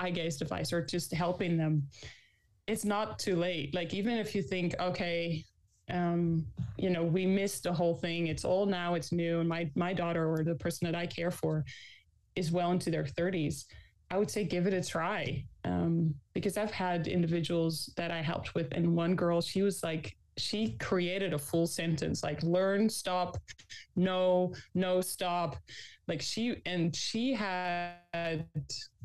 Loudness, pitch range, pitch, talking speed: -33 LUFS, 165-185 Hz, 175 Hz, 170 wpm